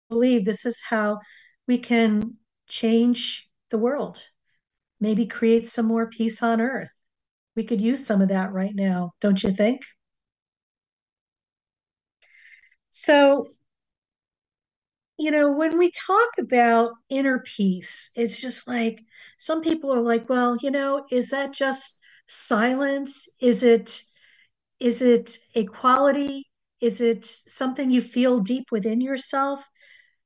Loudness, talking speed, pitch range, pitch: -23 LUFS, 125 wpm, 230-275 Hz, 245 Hz